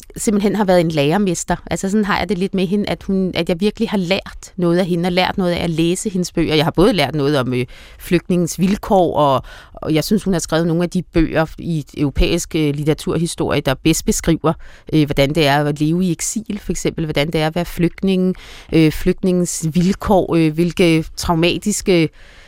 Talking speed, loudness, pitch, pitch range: 215 wpm, -17 LUFS, 170 Hz, 155-185 Hz